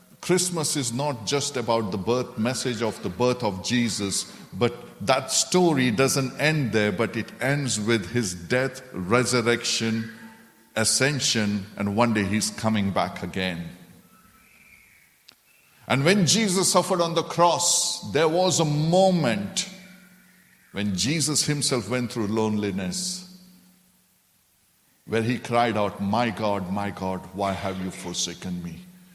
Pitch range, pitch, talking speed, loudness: 105-175 Hz, 125 Hz, 130 wpm, -24 LUFS